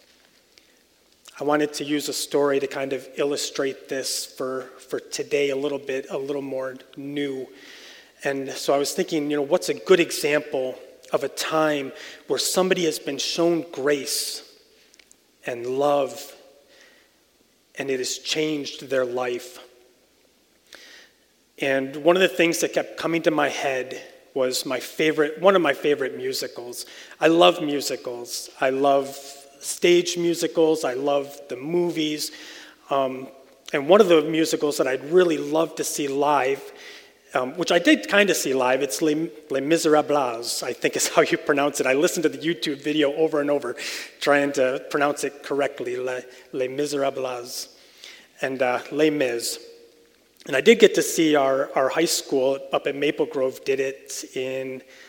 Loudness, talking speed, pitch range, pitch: -23 LUFS, 160 wpm, 135-170 Hz, 145 Hz